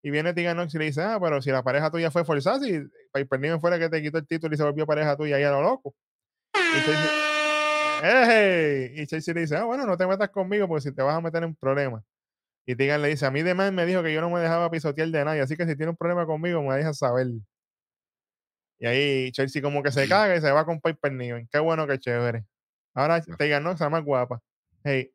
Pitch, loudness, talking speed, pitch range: 155 Hz, -24 LUFS, 255 wpm, 140-170 Hz